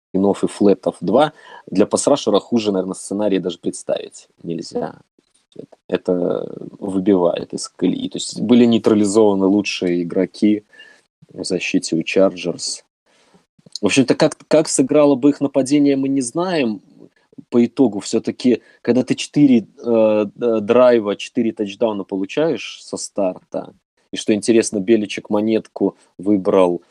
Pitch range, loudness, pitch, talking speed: 95-125 Hz, -18 LUFS, 110 Hz, 125 wpm